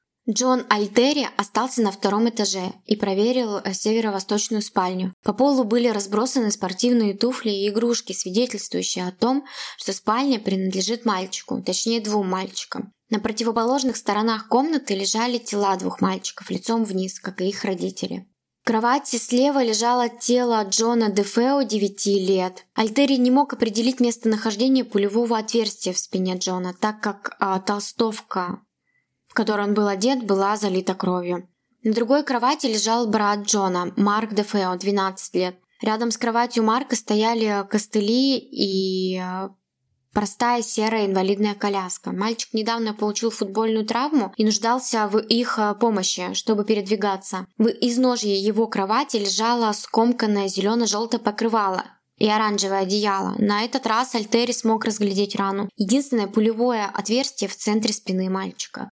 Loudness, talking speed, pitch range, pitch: -22 LUFS, 135 wpm, 200-235 Hz, 215 Hz